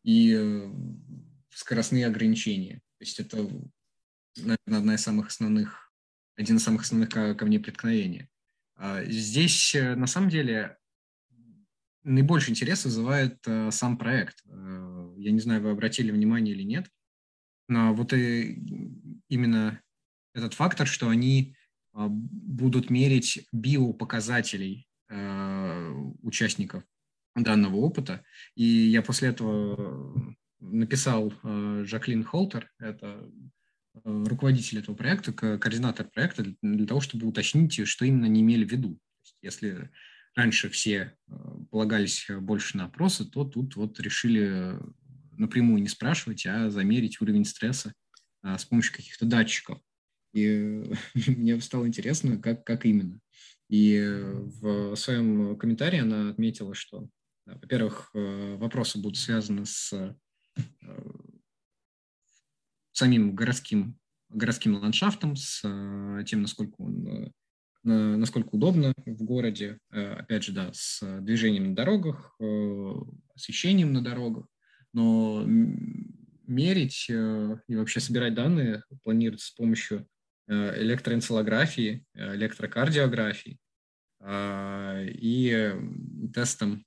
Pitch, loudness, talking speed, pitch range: 115 Hz, -27 LUFS, 100 wpm, 105-135 Hz